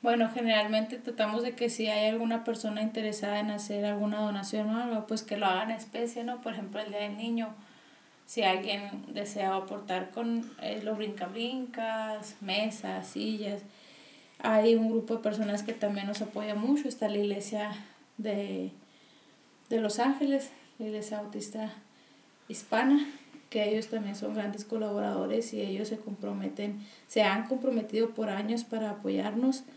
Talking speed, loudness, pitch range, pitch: 155 wpm, -32 LUFS, 210-230 Hz, 215 Hz